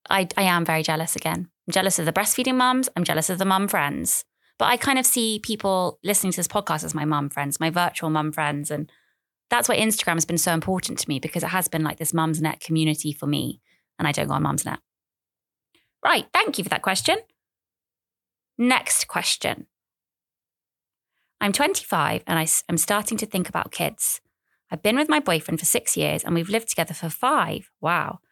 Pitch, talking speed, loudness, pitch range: 175 Hz, 205 wpm, -23 LUFS, 160-210 Hz